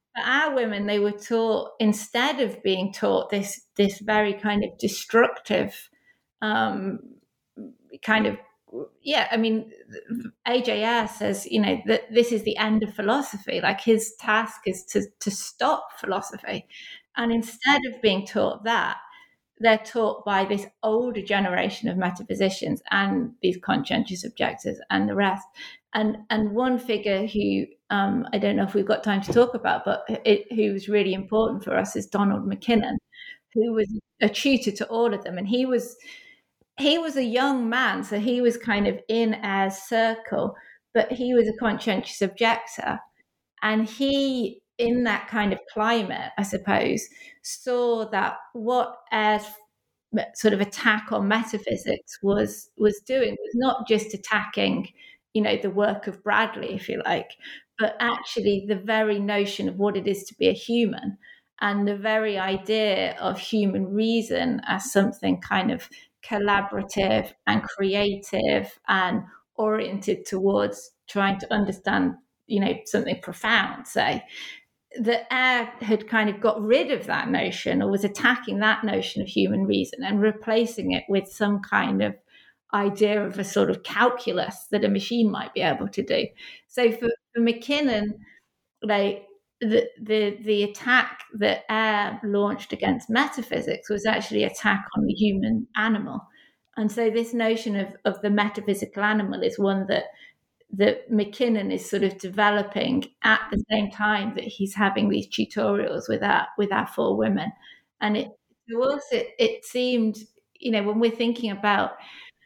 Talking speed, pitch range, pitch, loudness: 160 wpm, 205-235 Hz, 220 Hz, -24 LUFS